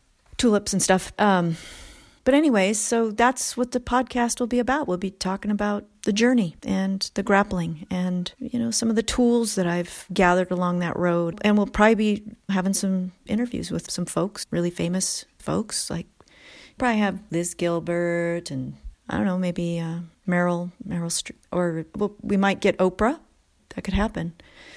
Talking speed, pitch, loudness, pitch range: 175 wpm, 195 Hz, -24 LUFS, 175-225 Hz